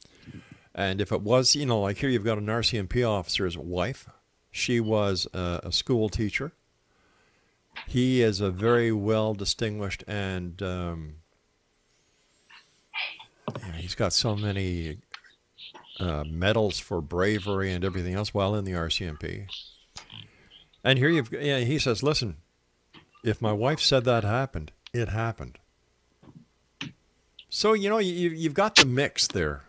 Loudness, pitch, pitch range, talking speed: -26 LUFS, 100 Hz, 85-115 Hz, 135 wpm